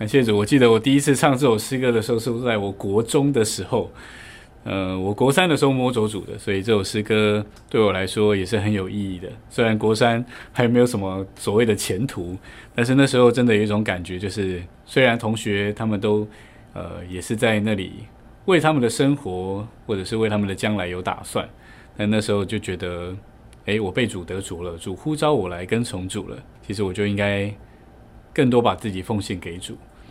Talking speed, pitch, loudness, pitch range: 300 characters per minute, 105 Hz, -21 LUFS, 95-120 Hz